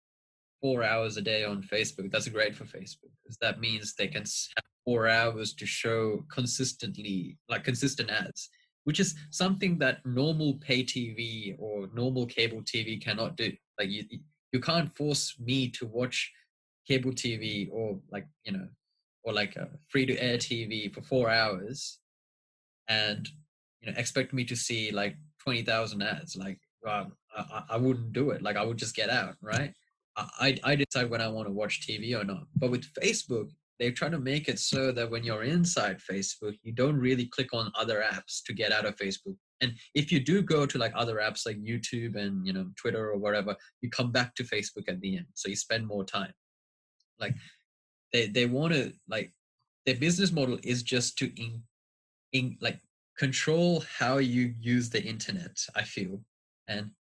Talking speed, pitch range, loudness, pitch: 185 wpm, 110-135 Hz, -31 LUFS, 120 Hz